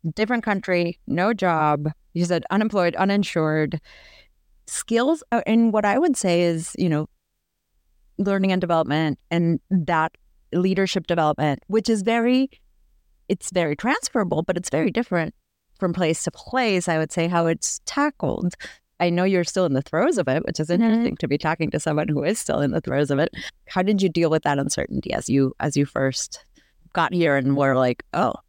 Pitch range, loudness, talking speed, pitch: 155-195 Hz, -22 LUFS, 185 wpm, 175 Hz